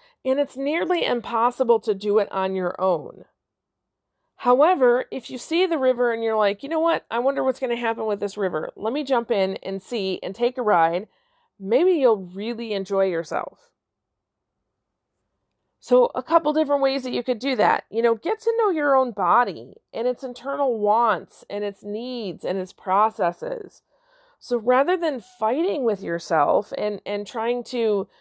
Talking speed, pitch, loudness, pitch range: 180 wpm, 235 Hz, -23 LUFS, 205-270 Hz